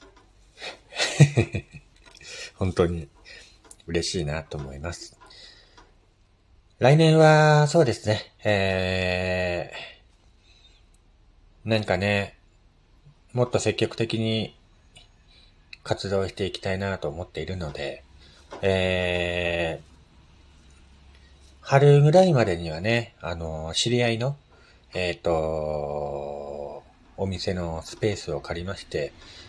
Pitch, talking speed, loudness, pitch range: 90 Hz, 175 characters per minute, -24 LUFS, 80-105 Hz